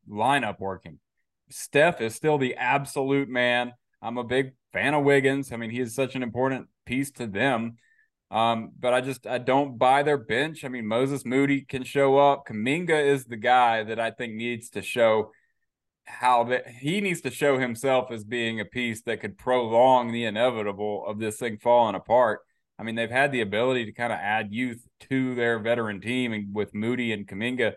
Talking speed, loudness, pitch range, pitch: 195 wpm, -25 LUFS, 115-135 Hz, 125 Hz